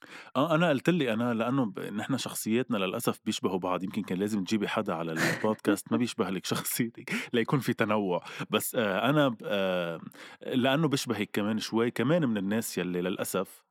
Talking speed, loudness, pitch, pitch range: 165 wpm, -29 LUFS, 110 Hz, 105-120 Hz